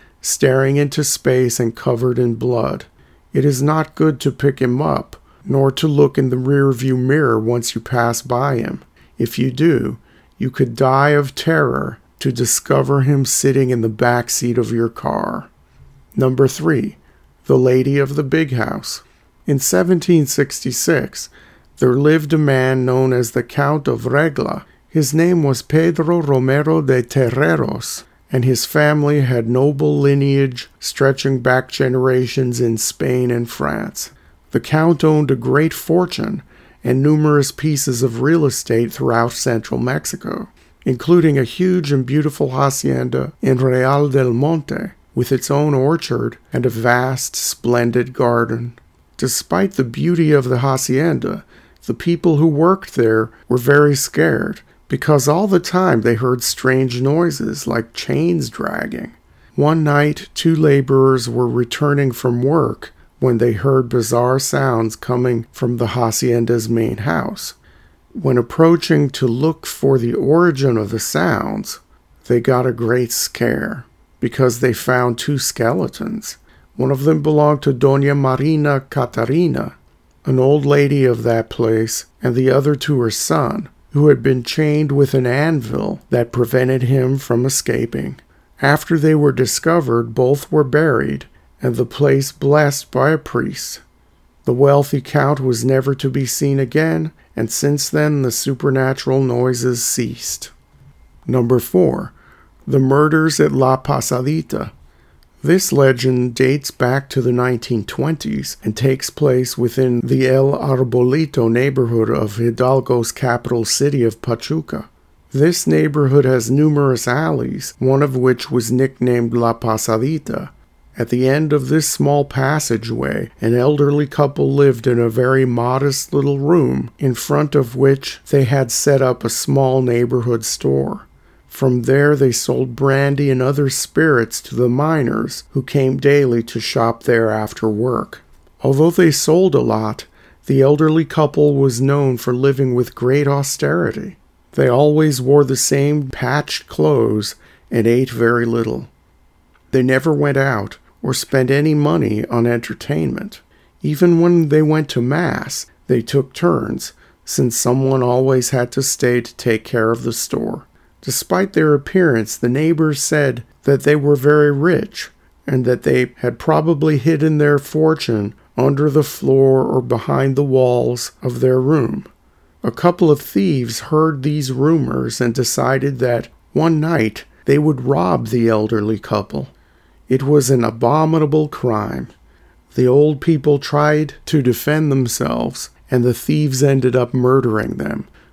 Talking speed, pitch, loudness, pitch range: 145 wpm, 130 Hz, -16 LUFS, 120-145 Hz